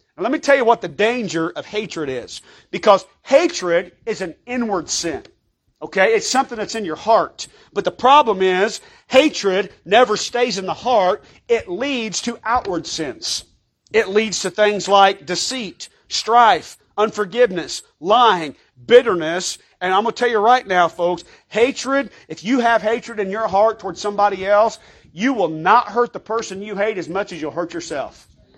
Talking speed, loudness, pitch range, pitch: 170 wpm, -18 LUFS, 185-240 Hz, 210 Hz